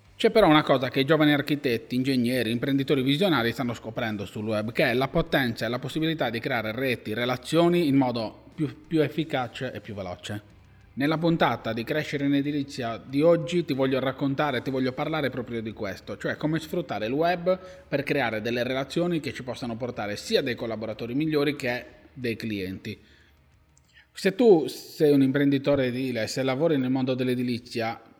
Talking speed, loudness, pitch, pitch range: 175 wpm, -26 LUFS, 130 Hz, 115-150 Hz